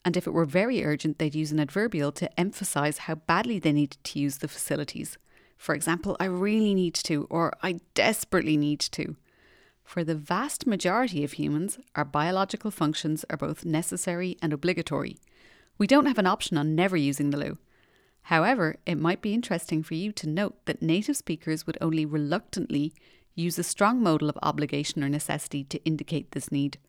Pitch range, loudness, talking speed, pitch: 150-185 Hz, -27 LUFS, 185 wpm, 165 Hz